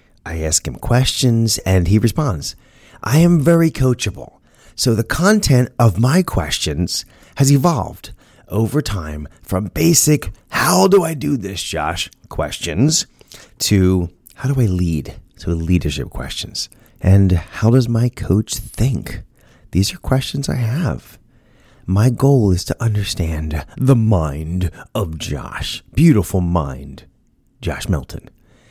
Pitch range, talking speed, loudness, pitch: 90-130 Hz, 130 wpm, -17 LUFS, 110 Hz